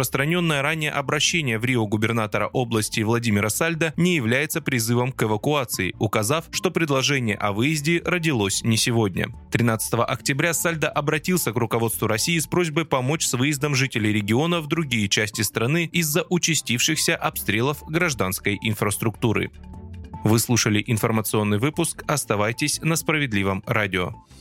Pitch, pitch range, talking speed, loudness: 125 Hz, 110-155 Hz, 130 wpm, -22 LUFS